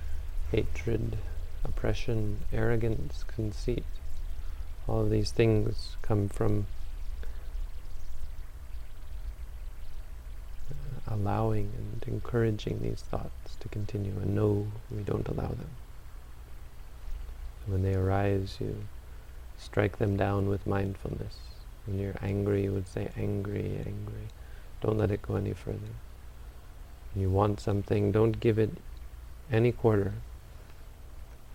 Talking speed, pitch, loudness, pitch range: 110 wpm, 100 Hz, -32 LUFS, 70-105 Hz